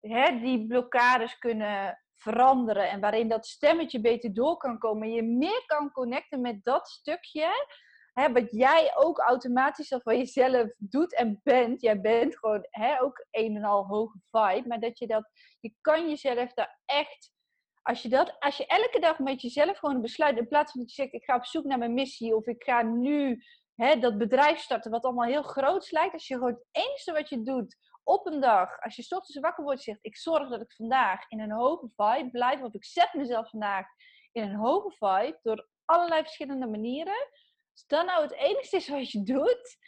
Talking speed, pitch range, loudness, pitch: 205 wpm, 230-300 Hz, -28 LUFS, 255 Hz